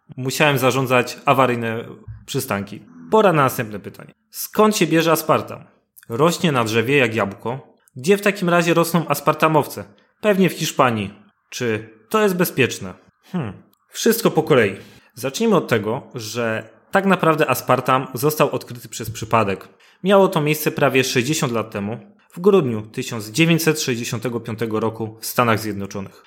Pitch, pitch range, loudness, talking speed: 130 Hz, 115-165 Hz, -19 LUFS, 135 wpm